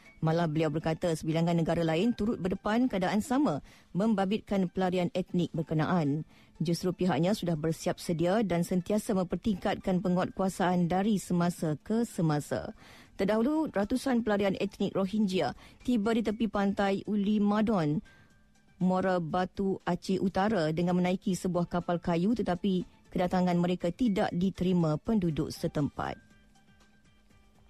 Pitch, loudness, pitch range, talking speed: 185 Hz, -30 LUFS, 175-205 Hz, 115 wpm